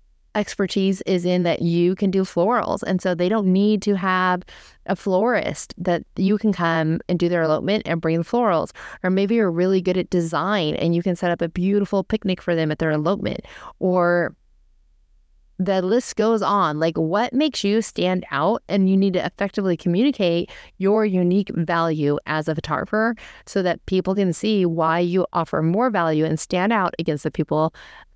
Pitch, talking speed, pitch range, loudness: 185 Hz, 190 wpm, 165-200 Hz, -21 LUFS